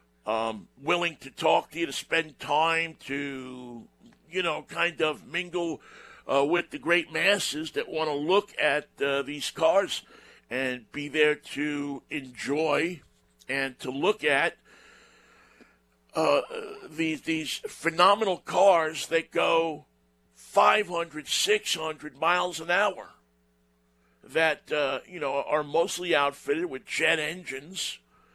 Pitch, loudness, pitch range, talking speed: 150 Hz, -27 LUFS, 135-170 Hz, 125 wpm